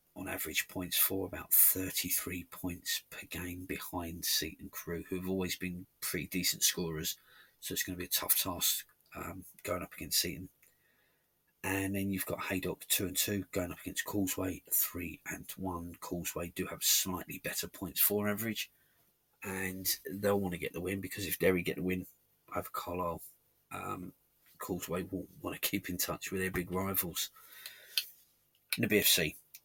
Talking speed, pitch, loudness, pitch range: 170 wpm, 95 Hz, -34 LUFS, 90-95 Hz